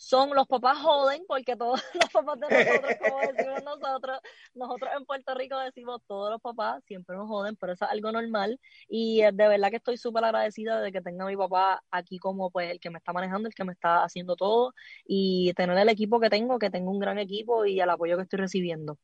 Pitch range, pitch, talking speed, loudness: 185-250 Hz, 210 Hz, 230 wpm, -27 LUFS